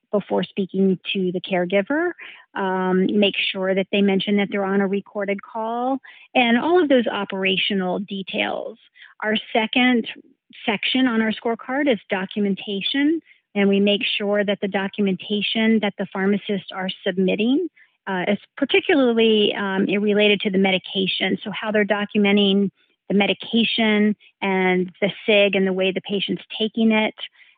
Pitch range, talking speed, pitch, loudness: 195-230 Hz, 145 wpm, 205 Hz, -21 LUFS